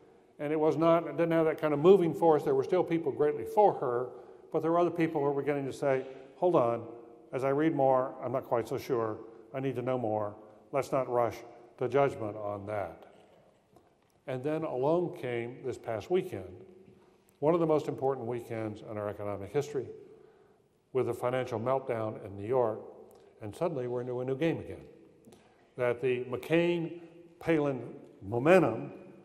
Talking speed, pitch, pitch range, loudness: 180 wpm, 135 Hz, 120-165 Hz, -31 LUFS